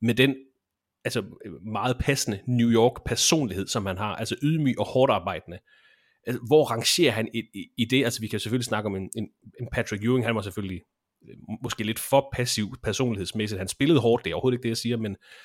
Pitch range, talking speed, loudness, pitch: 105-125 Hz, 205 wpm, -25 LUFS, 115 Hz